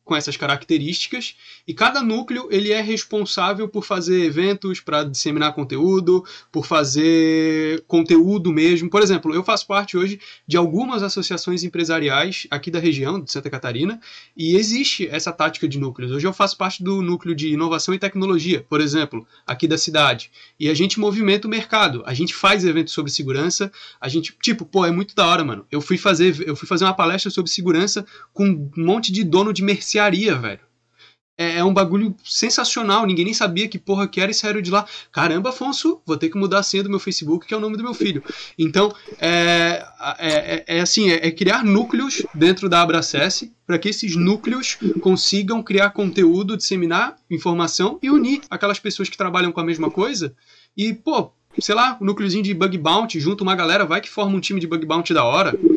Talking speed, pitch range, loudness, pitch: 195 wpm, 165-205 Hz, -19 LUFS, 185 Hz